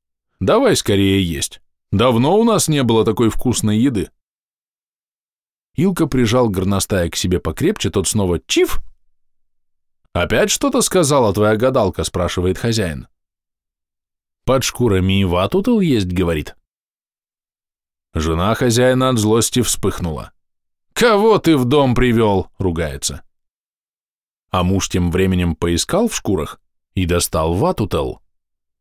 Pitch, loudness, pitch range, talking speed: 100 Hz, -16 LUFS, 85-125 Hz, 110 wpm